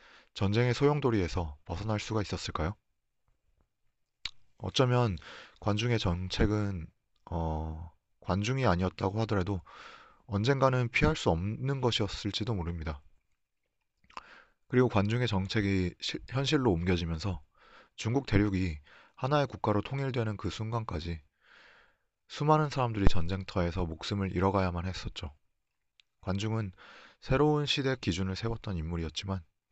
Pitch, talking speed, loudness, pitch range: 100 Hz, 285 characters per minute, -31 LUFS, 90-120 Hz